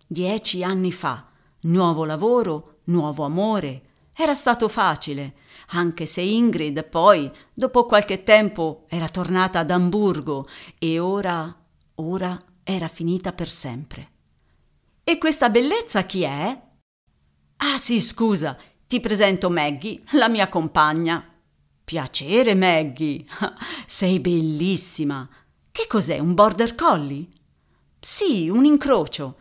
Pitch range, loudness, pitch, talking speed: 155-210 Hz, -21 LUFS, 175 Hz, 110 wpm